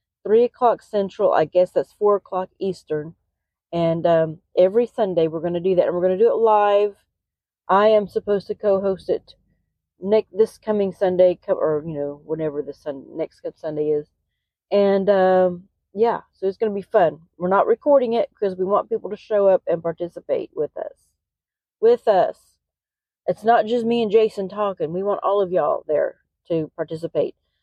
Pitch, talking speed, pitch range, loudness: 195 Hz, 185 wpm, 170-215 Hz, -21 LUFS